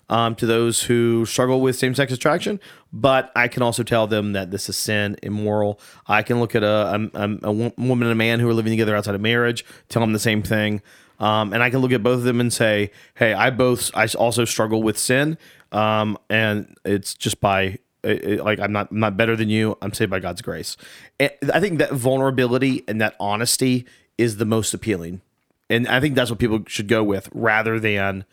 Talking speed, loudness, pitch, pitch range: 220 wpm, -20 LUFS, 115 Hz, 105-120 Hz